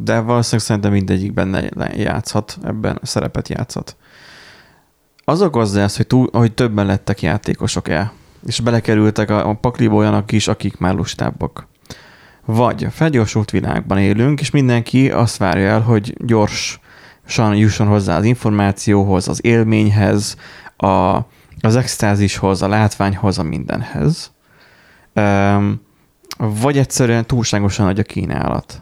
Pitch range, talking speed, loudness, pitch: 100-115 Hz, 125 wpm, -16 LUFS, 105 Hz